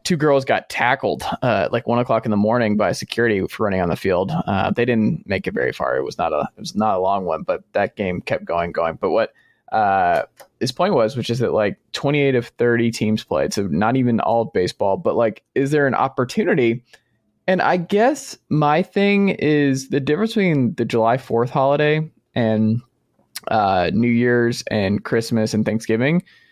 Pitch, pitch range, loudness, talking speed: 120 Hz, 115-150 Hz, -19 LUFS, 205 wpm